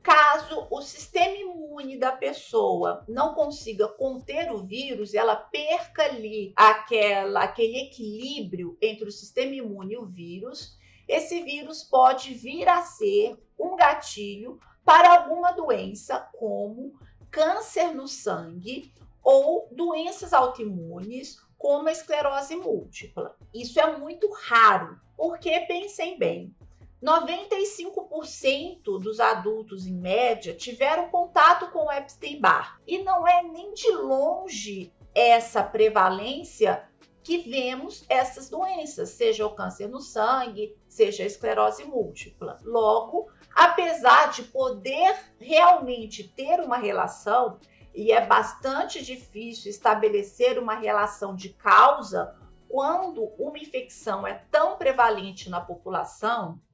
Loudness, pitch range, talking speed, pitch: -24 LUFS, 215-335 Hz, 115 wpm, 270 Hz